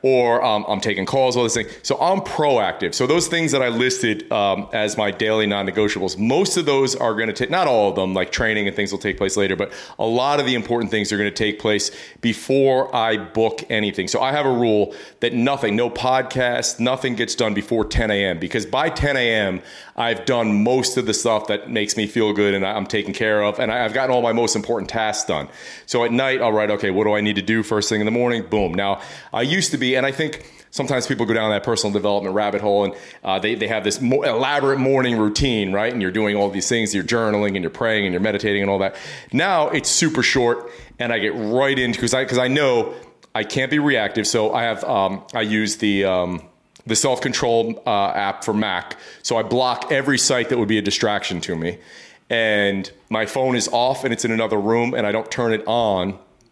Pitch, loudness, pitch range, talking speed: 110 Hz, -20 LUFS, 105-125 Hz, 240 wpm